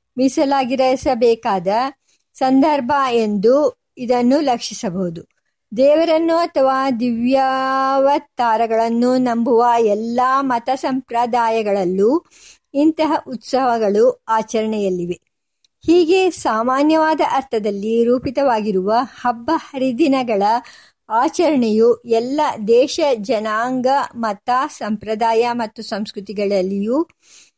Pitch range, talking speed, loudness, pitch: 225-275 Hz, 65 wpm, -17 LUFS, 245 Hz